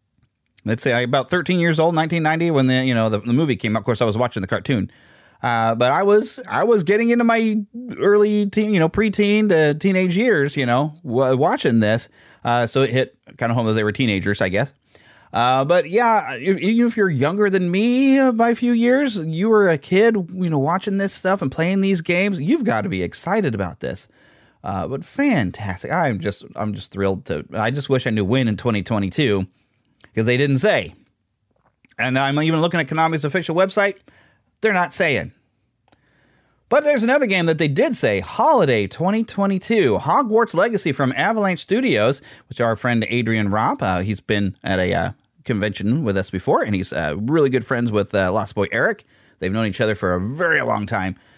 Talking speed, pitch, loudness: 205 wpm, 145 Hz, -19 LUFS